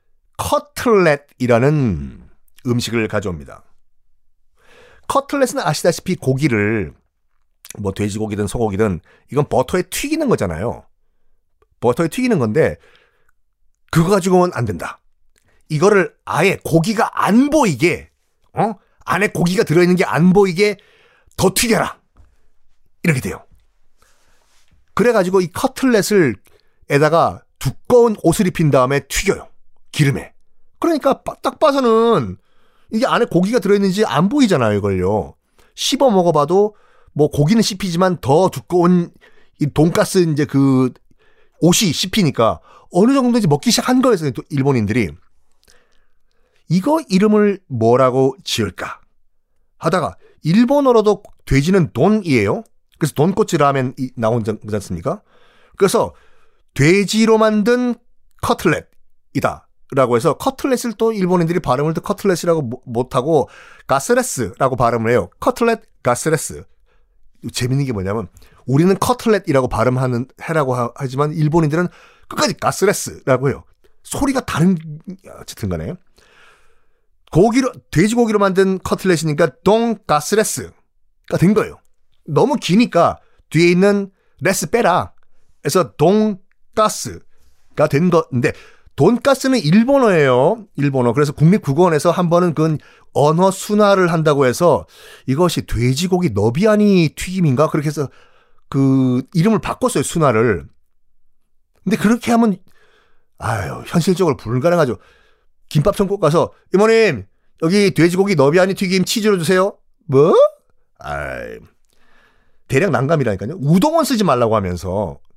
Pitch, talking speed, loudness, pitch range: 175 Hz, 280 characters per minute, -16 LUFS, 135-210 Hz